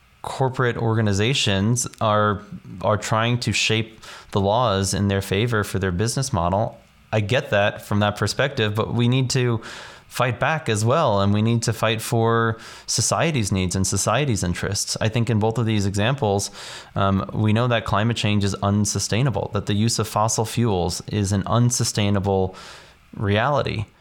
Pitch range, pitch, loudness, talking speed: 100-115 Hz, 110 Hz, -21 LUFS, 165 wpm